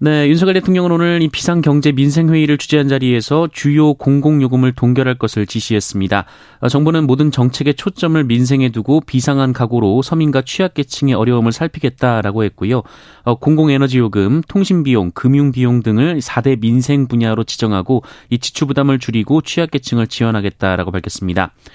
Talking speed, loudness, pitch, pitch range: 390 characters per minute, -14 LUFS, 135 Hz, 115-150 Hz